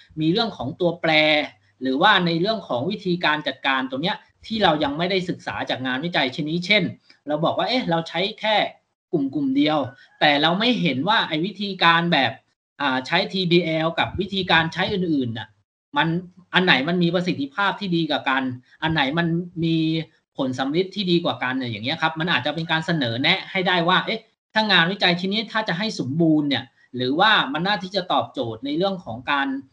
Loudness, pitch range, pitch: -21 LUFS, 150-190 Hz, 170 Hz